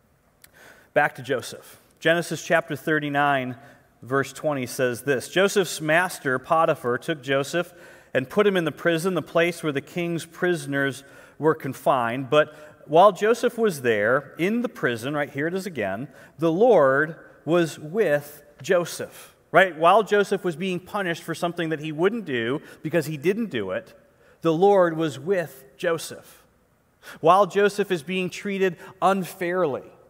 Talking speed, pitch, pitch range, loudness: 150 wpm, 165 Hz, 145-185 Hz, -23 LUFS